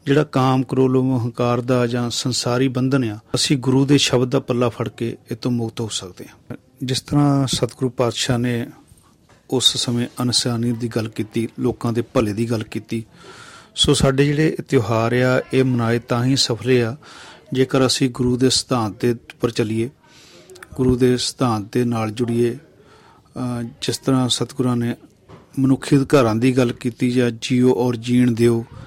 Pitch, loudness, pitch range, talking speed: 125 Hz, -19 LUFS, 120-130 Hz, 165 wpm